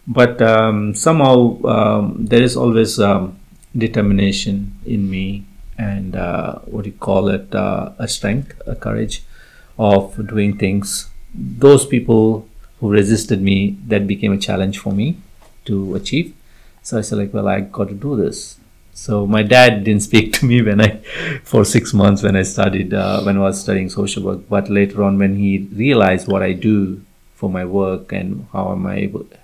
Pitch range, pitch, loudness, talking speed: 100-110 Hz, 100 Hz, -16 LUFS, 180 wpm